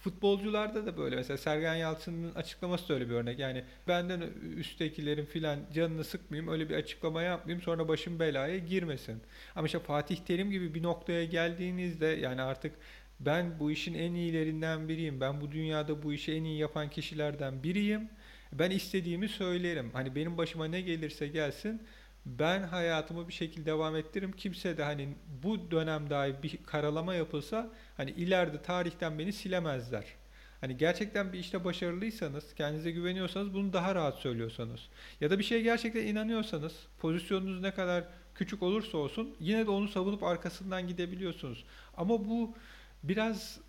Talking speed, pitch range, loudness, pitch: 155 wpm, 155-185 Hz, -35 LUFS, 170 Hz